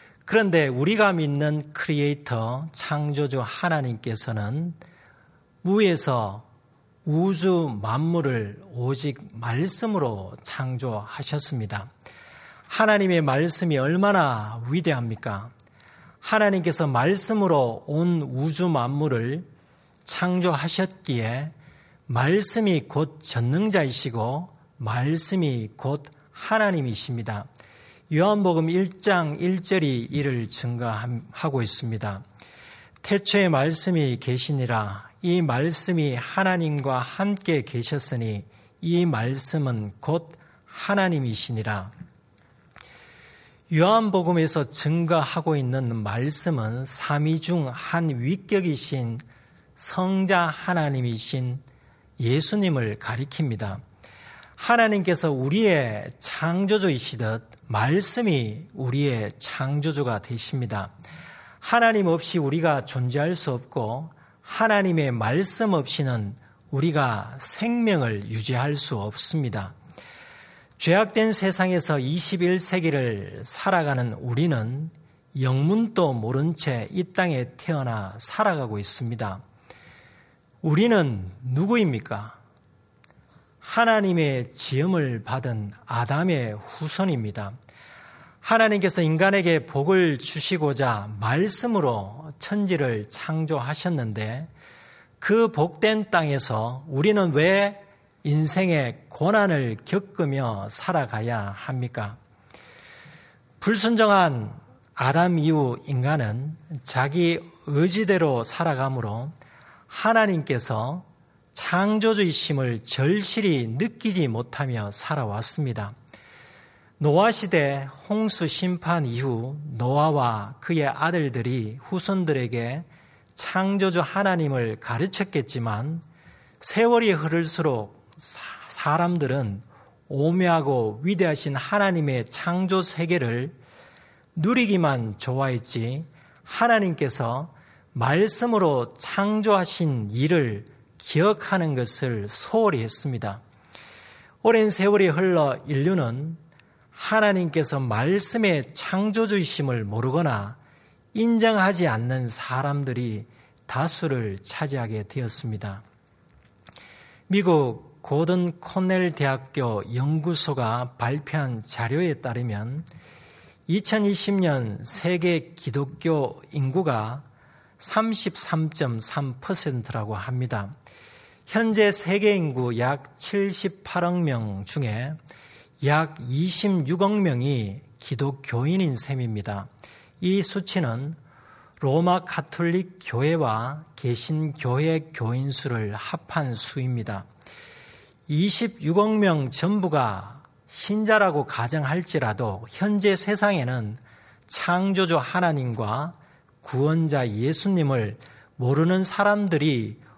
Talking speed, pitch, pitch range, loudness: 210 characters per minute, 150 Hz, 125-175 Hz, -24 LUFS